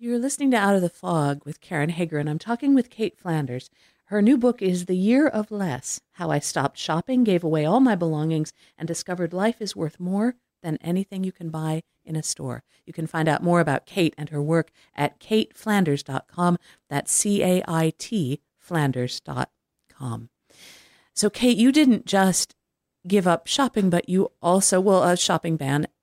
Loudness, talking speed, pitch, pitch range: -23 LUFS, 185 wpm, 175 Hz, 150-205 Hz